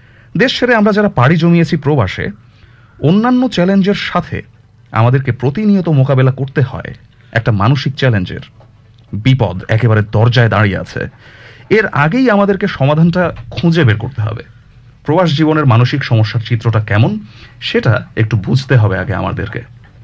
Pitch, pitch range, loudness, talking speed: 120 Hz, 115-155 Hz, -13 LUFS, 130 wpm